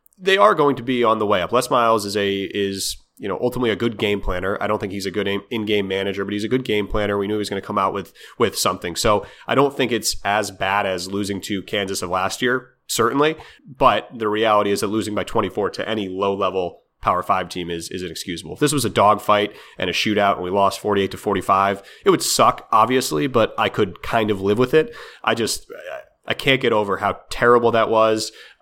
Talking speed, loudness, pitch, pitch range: 250 wpm, -20 LUFS, 105 Hz, 100-115 Hz